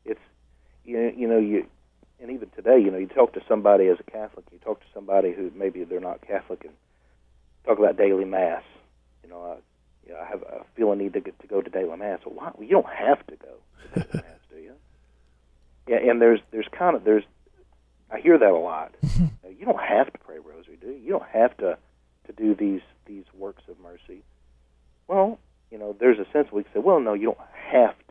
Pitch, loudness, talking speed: 95 Hz, -23 LUFS, 235 wpm